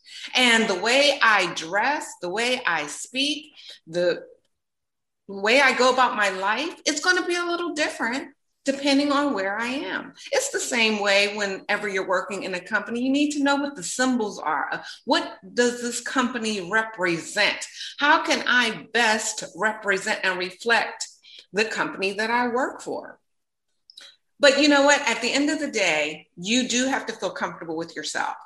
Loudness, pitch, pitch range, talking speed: -23 LUFS, 245 Hz, 205-285 Hz, 175 wpm